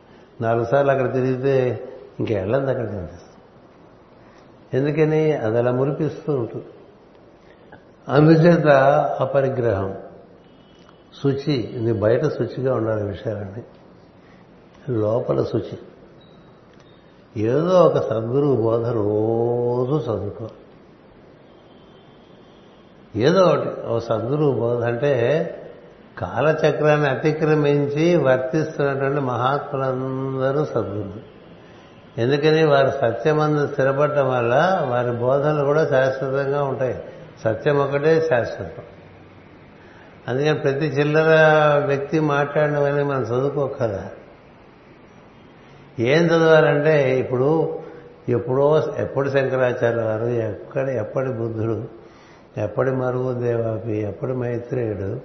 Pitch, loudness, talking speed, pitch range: 135 Hz, -20 LUFS, 85 wpm, 120-145 Hz